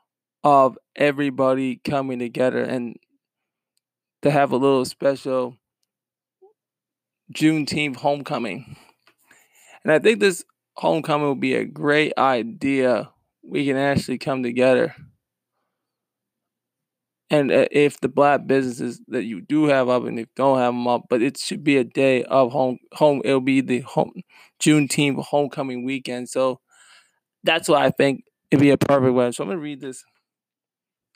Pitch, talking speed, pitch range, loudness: 135 Hz, 145 wpm, 130-145 Hz, -21 LUFS